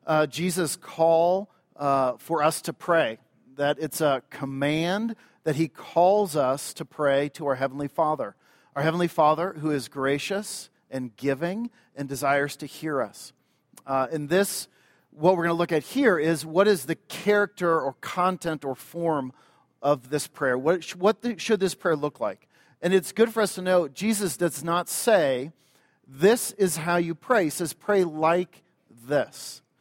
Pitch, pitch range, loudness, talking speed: 165 Hz, 145-185 Hz, -25 LUFS, 175 wpm